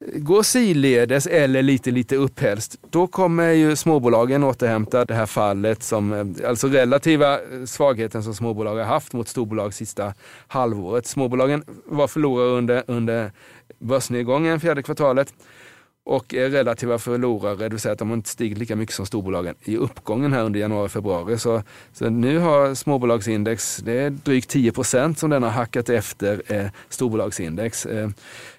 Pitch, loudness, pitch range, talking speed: 120 Hz, -21 LUFS, 110-140 Hz, 145 wpm